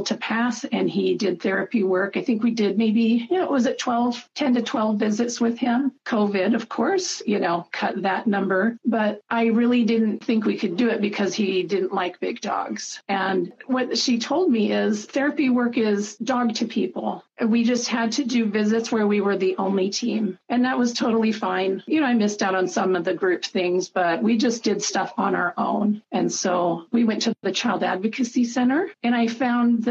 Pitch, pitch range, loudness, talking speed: 225 Hz, 195-245 Hz, -22 LUFS, 220 wpm